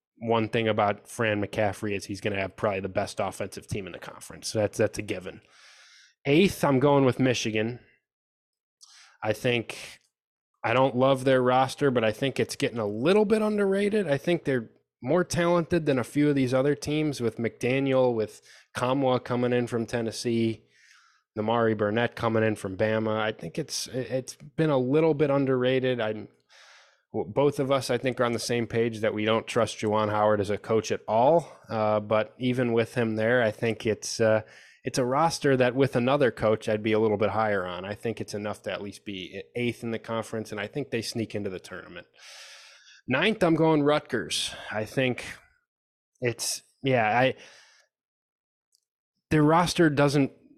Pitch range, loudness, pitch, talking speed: 110-135 Hz, -26 LUFS, 120 Hz, 185 wpm